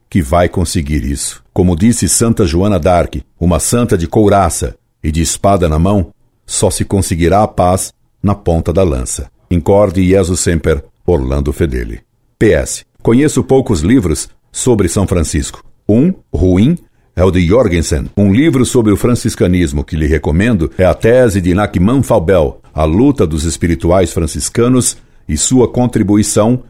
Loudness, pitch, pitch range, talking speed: -12 LUFS, 95 Hz, 85-110 Hz, 150 wpm